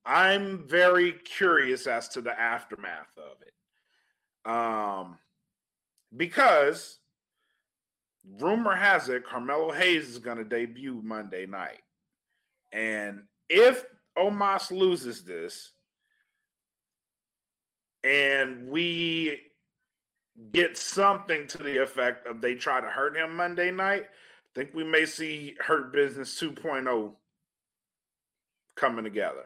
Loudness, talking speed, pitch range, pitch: -27 LUFS, 105 wpm, 120-185 Hz, 160 Hz